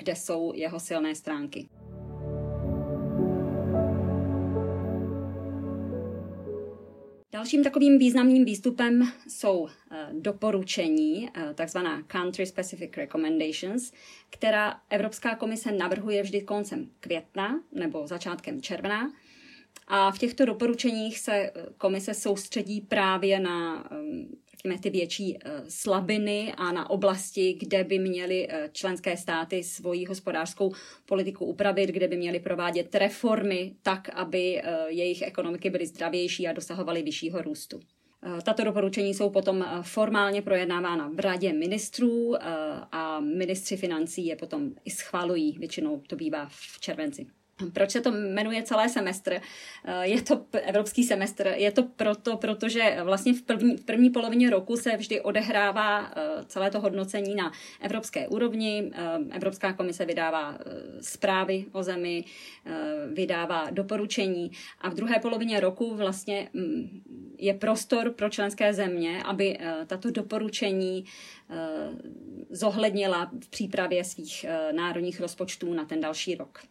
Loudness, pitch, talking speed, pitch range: -28 LUFS, 195 Hz, 115 wpm, 175-225 Hz